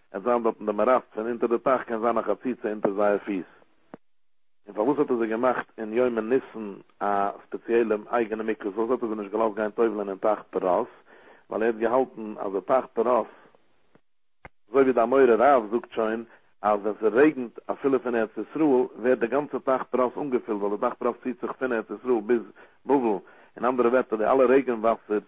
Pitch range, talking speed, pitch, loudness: 110-125 Hz, 215 wpm, 115 Hz, -25 LUFS